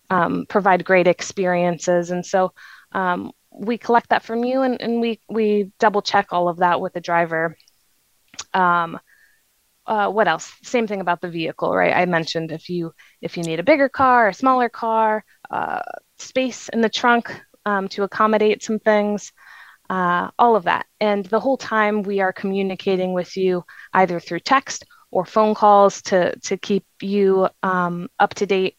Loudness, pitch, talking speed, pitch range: -20 LUFS, 200 Hz, 175 wpm, 180-220 Hz